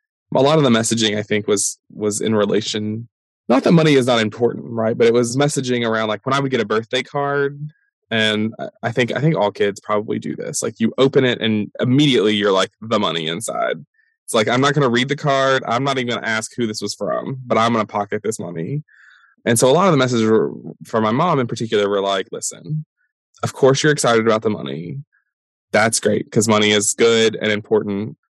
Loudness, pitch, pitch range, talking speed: -18 LUFS, 115 Hz, 110-140 Hz, 230 wpm